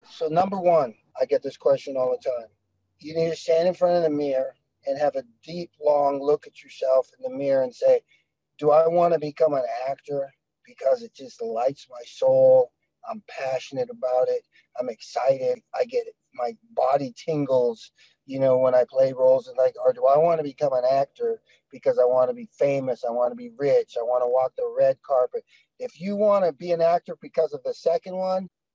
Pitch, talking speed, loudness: 165 Hz, 215 wpm, -24 LUFS